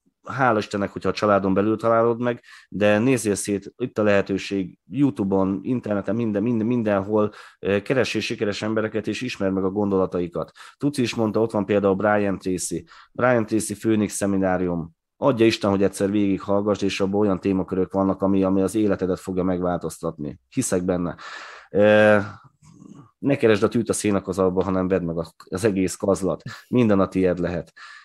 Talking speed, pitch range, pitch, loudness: 155 wpm, 95-110 Hz, 100 Hz, -22 LUFS